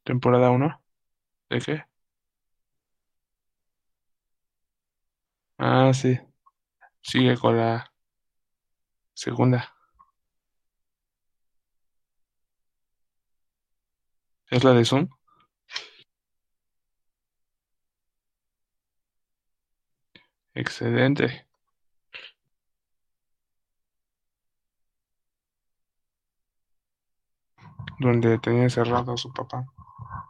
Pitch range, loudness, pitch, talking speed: 80-125 Hz, -23 LUFS, 115 Hz, 40 wpm